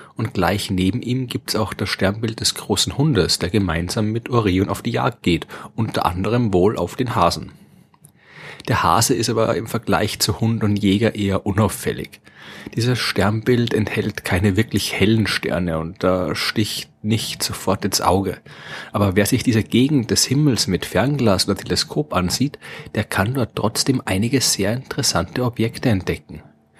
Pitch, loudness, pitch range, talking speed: 105 Hz, -19 LUFS, 95-115 Hz, 160 wpm